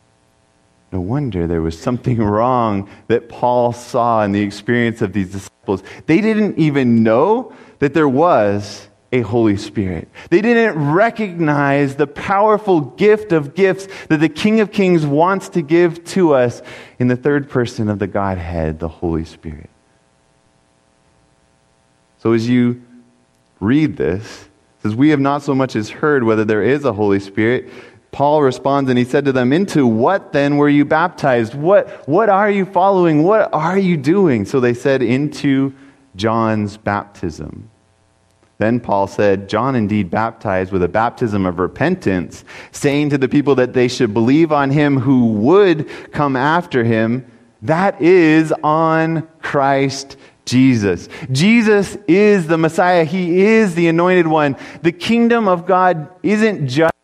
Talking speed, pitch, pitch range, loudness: 155 wpm, 130 Hz, 105-160 Hz, -15 LUFS